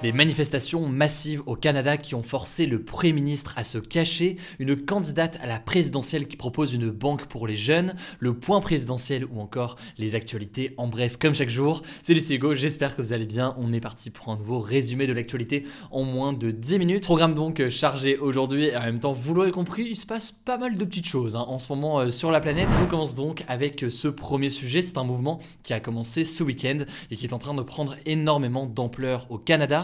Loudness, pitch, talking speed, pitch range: -25 LUFS, 140 Hz, 225 wpm, 125-155 Hz